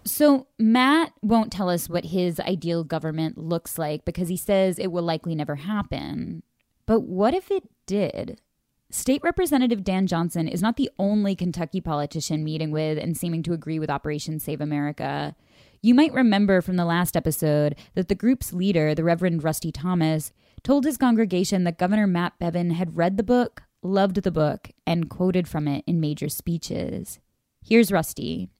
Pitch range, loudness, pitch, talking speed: 160-205 Hz, -24 LUFS, 175 Hz, 170 wpm